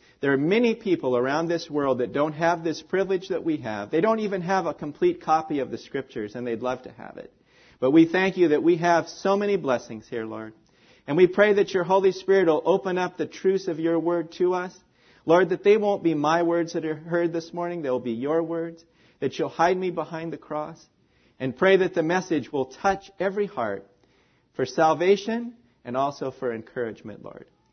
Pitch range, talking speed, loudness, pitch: 145-185 Hz, 215 wpm, -24 LUFS, 165 Hz